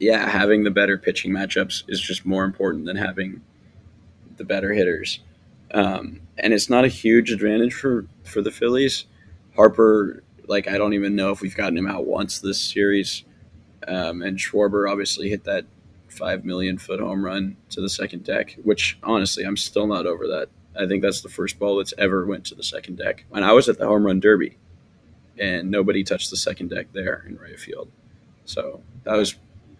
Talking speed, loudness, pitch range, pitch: 190 wpm, -22 LUFS, 95-105 Hz, 100 Hz